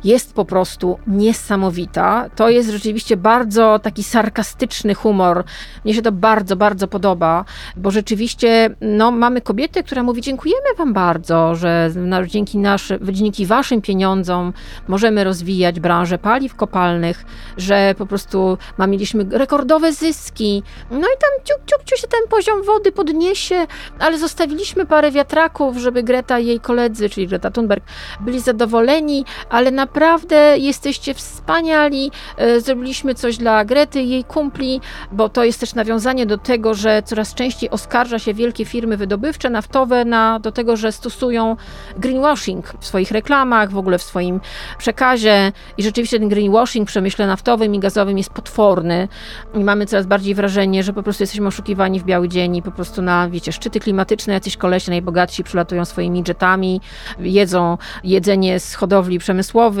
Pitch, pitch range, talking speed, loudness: 220 Hz, 195-250 Hz, 155 wpm, -16 LUFS